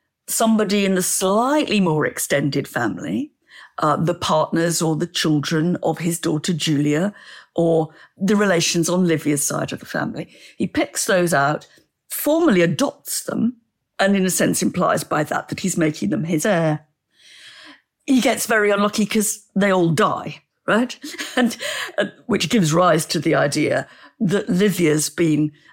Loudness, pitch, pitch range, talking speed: -20 LUFS, 180 Hz, 160-215 Hz, 155 wpm